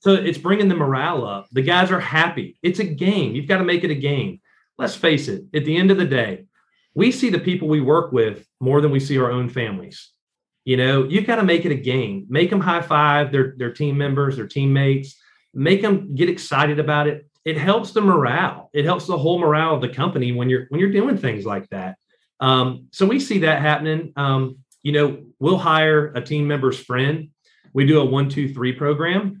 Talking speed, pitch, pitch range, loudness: 225 wpm, 150 Hz, 135-175 Hz, -19 LUFS